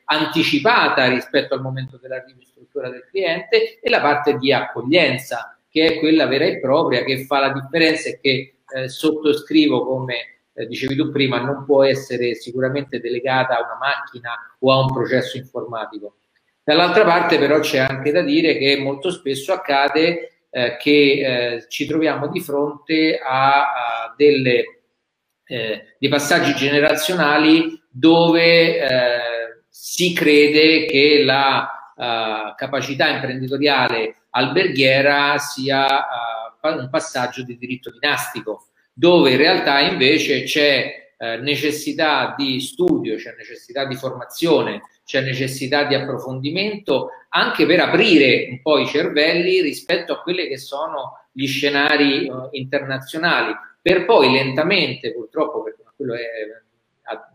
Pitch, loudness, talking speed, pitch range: 140 Hz, -17 LUFS, 135 wpm, 130-155 Hz